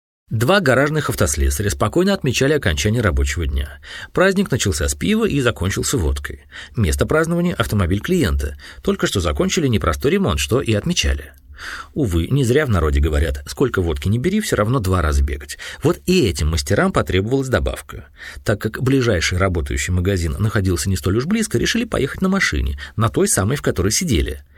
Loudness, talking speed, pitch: -19 LUFS, 165 wpm, 95 Hz